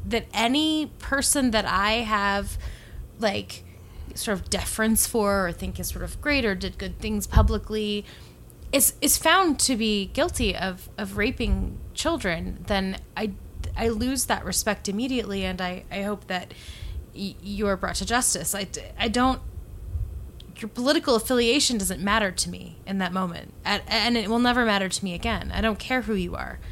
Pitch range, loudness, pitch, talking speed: 185-240 Hz, -25 LUFS, 210 Hz, 175 wpm